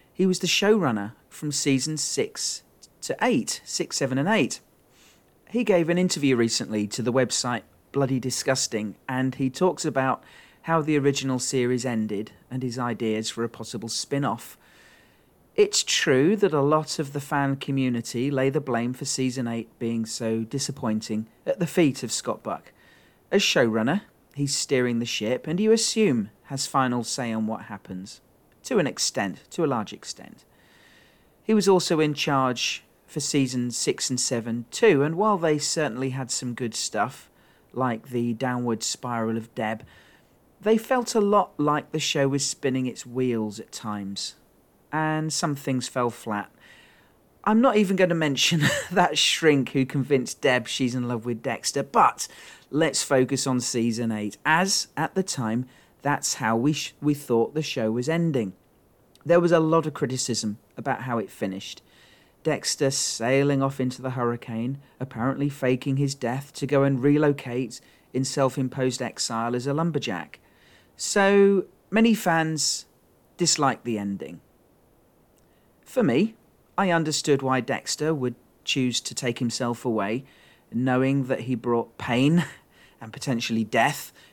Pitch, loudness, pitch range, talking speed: 130 Hz, -25 LUFS, 120-150 Hz, 155 wpm